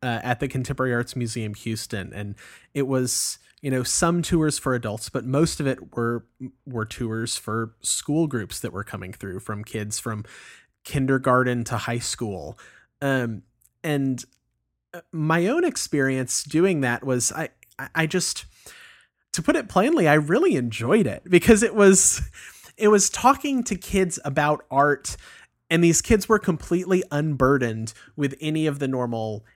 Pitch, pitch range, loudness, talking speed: 130 Hz, 115-155 Hz, -23 LUFS, 155 wpm